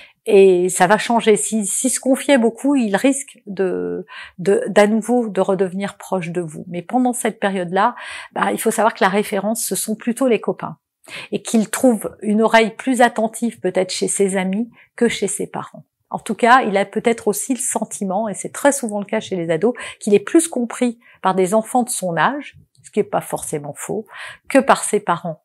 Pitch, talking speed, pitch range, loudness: 215 Hz, 210 wpm, 195-240 Hz, -18 LUFS